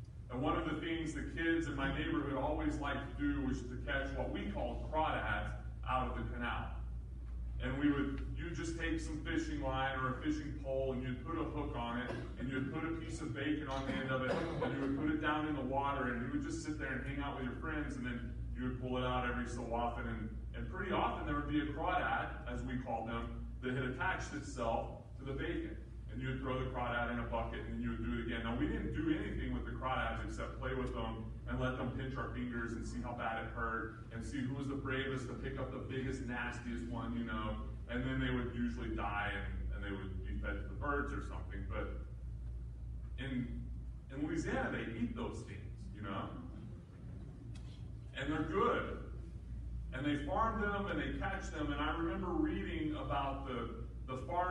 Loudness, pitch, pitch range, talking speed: -40 LUFS, 125 Hz, 115-140 Hz, 230 wpm